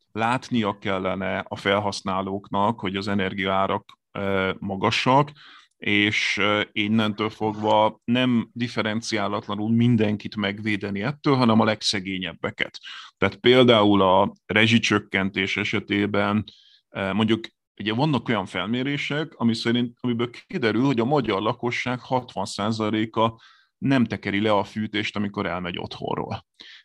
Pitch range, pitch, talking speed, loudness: 100-120 Hz, 105 Hz, 105 wpm, -23 LUFS